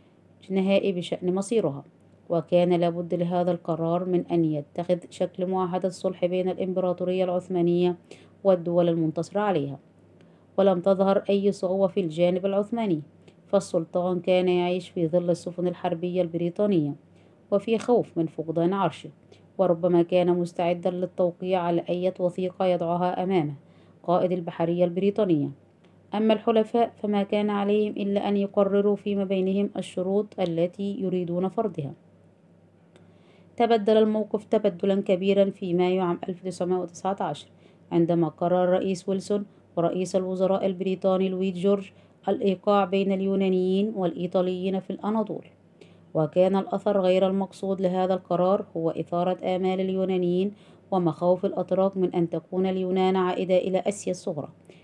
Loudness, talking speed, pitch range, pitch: -25 LUFS, 120 wpm, 175-195 Hz, 185 Hz